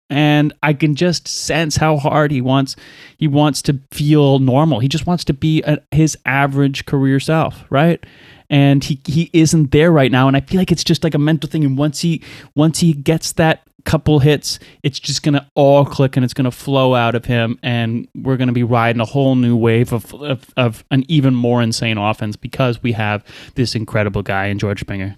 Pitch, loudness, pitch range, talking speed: 140 Hz, -15 LUFS, 125-155 Hz, 210 wpm